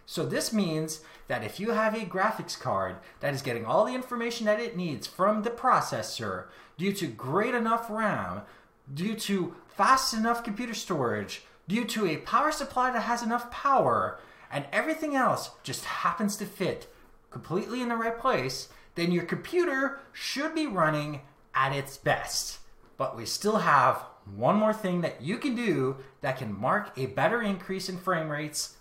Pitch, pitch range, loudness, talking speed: 200 Hz, 155-235 Hz, -29 LUFS, 175 wpm